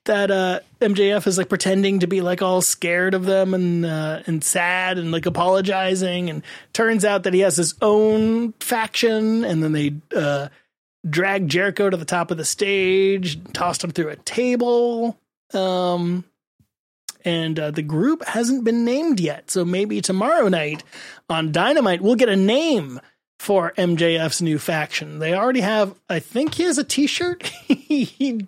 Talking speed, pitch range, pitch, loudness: 165 wpm, 170-220 Hz, 190 Hz, -20 LUFS